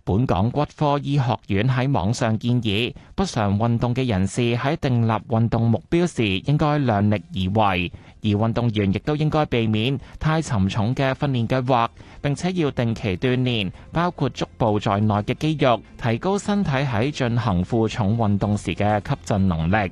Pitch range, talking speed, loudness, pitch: 105-140 Hz, 255 characters per minute, -22 LUFS, 115 Hz